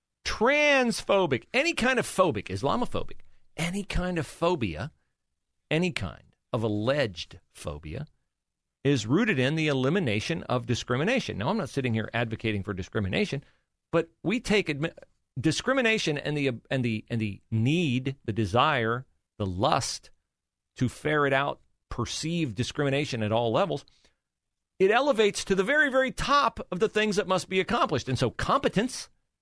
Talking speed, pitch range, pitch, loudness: 145 wpm, 115-190 Hz, 145 Hz, -27 LUFS